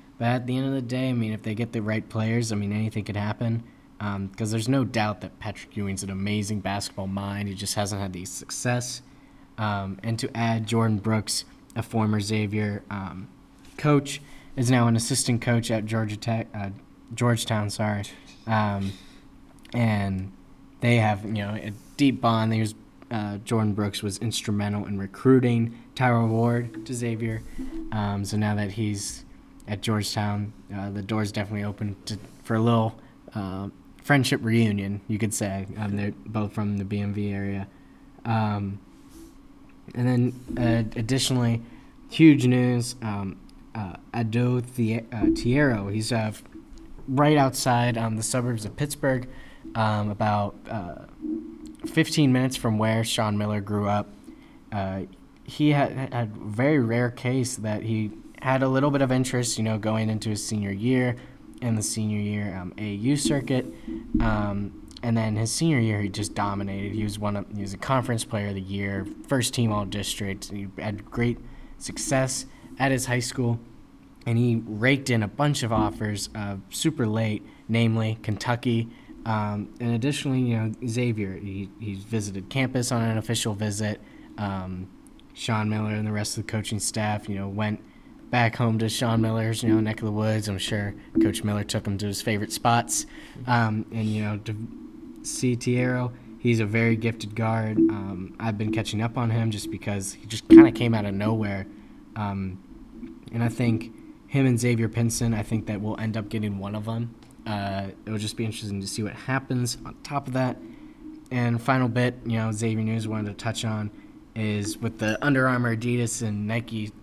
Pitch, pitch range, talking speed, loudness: 110 Hz, 105-120 Hz, 175 wpm, -26 LUFS